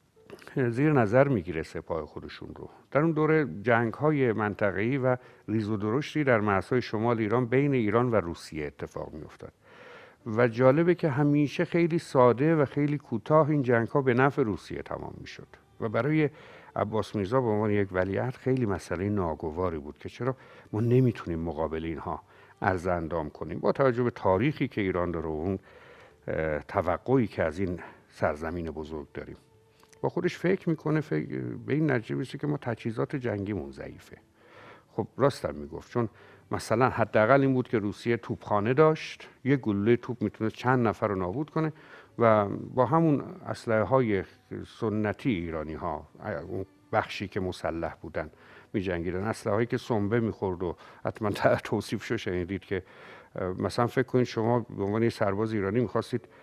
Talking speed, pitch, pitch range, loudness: 165 wpm, 115 Hz, 95-130 Hz, -28 LUFS